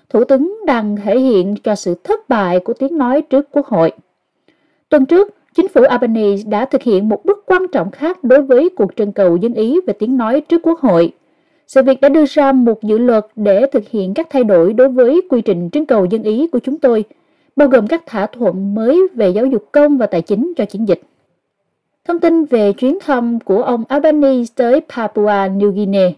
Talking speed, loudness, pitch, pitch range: 215 wpm, -13 LUFS, 250 Hz, 210-290 Hz